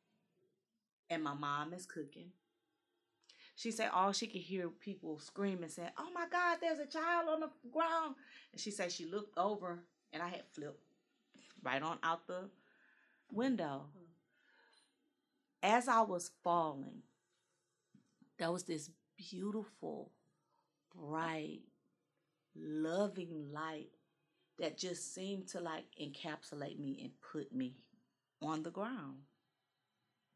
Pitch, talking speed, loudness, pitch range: 180 Hz, 125 wpm, -41 LUFS, 160-225 Hz